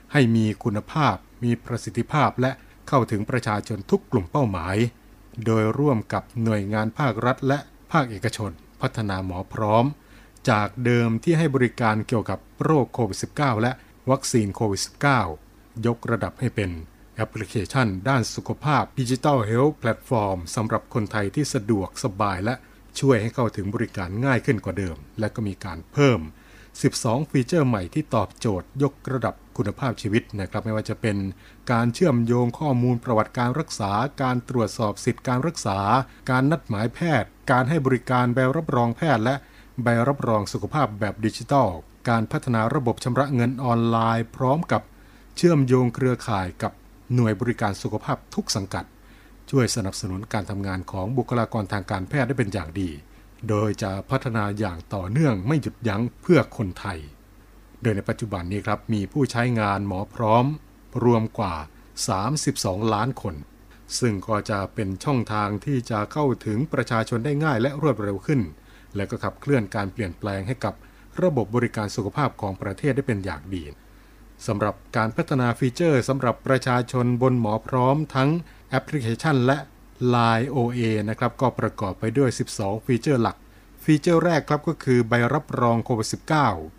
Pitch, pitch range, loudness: 115 Hz, 105-130 Hz, -24 LUFS